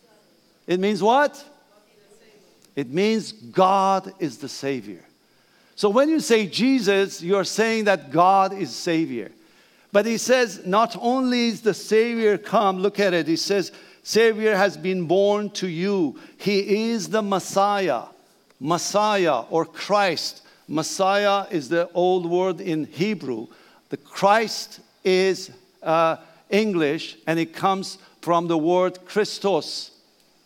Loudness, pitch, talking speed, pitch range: -22 LUFS, 195 Hz, 130 wpm, 175-215 Hz